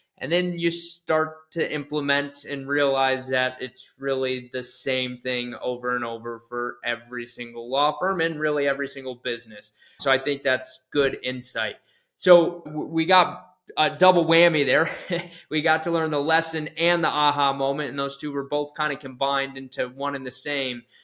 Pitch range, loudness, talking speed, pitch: 130-160 Hz, -24 LUFS, 185 wpm, 140 Hz